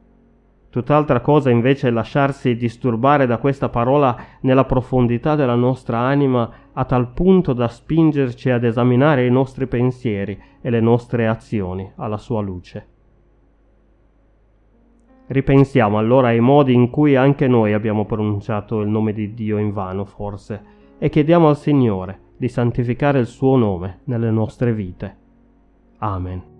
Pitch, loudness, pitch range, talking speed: 120 Hz, -18 LUFS, 105-135 Hz, 140 wpm